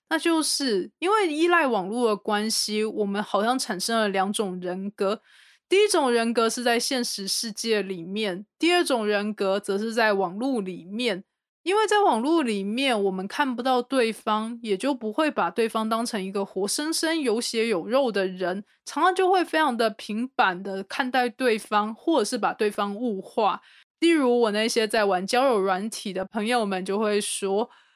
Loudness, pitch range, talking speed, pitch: -24 LUFS, 205-260 Hz, 260 characters per minute, 225 Hz